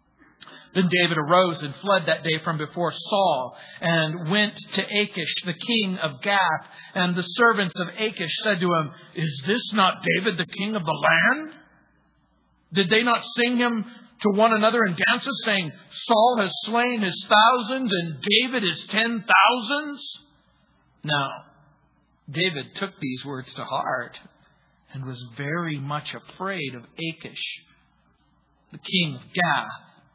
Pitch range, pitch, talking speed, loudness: 165-220 Hz, 190 Hz, 145 wpm, -22 LUFS